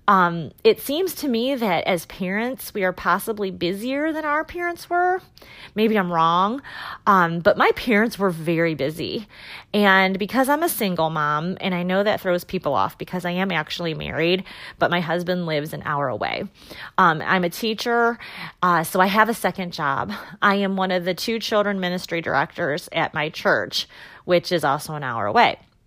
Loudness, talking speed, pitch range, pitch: -21 LUFS, 185 wpm, 170-225 Hz, 185 Hz